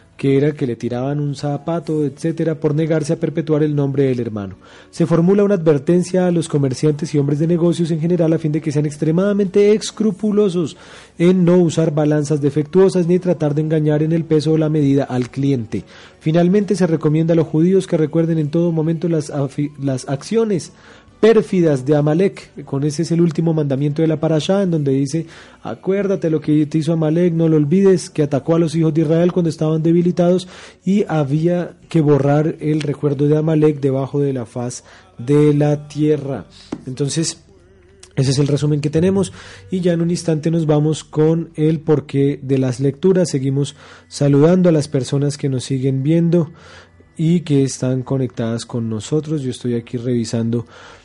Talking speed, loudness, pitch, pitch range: 185 wpm, -17 LUFS, 155 Hz, 140-170 Hz